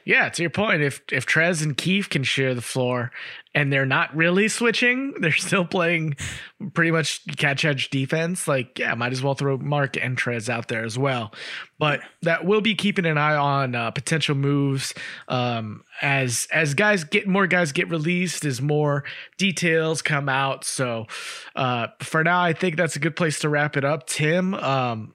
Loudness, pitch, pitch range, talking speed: -22 LUFS, 150 Hz, 135-175 Hz, 190 wpm